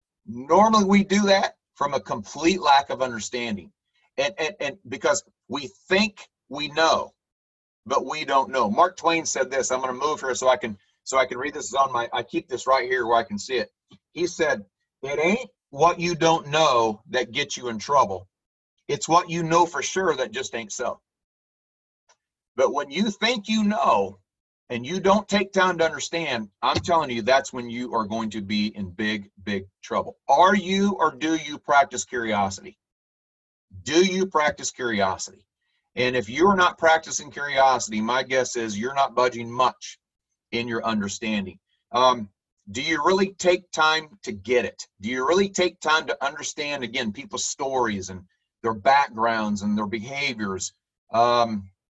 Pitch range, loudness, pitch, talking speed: 110-175 Hz, -23 LUFS, 135 Hz, 175 wpm